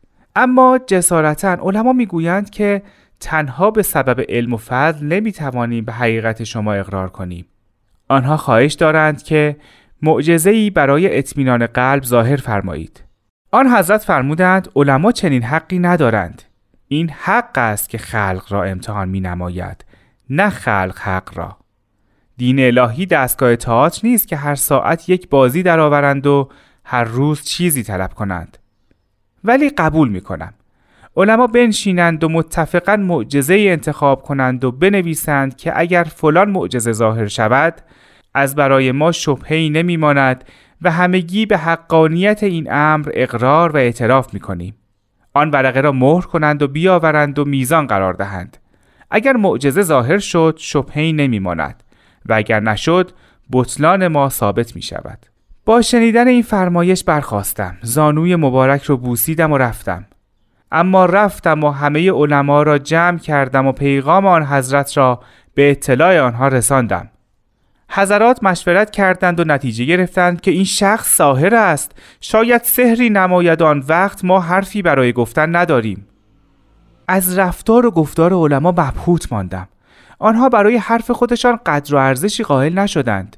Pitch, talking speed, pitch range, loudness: 145 Hz, 135 wpm, 120-180 Hz, -14 LUFS